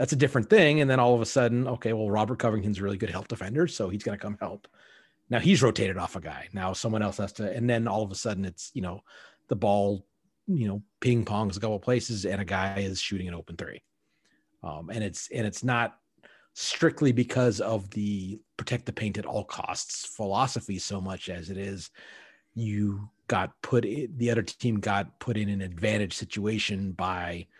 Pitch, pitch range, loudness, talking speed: 105 Hz, 100-120 Hz, -28 LUFS, 215 wpm